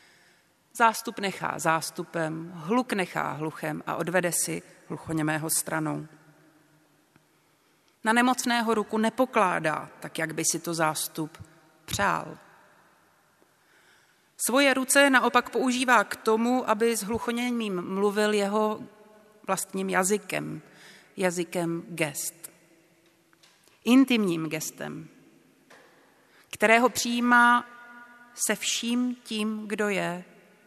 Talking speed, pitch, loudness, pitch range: 90 wpm, 200 Hz, -26 LUFS, 165-235 Hz